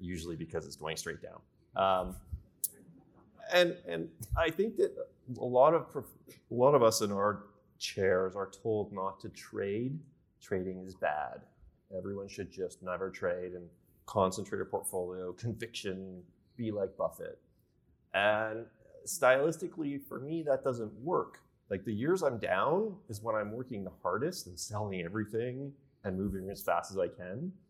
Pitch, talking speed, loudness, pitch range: 110 Hz, 155 wpm, -34 LUFS, 95-135 Hz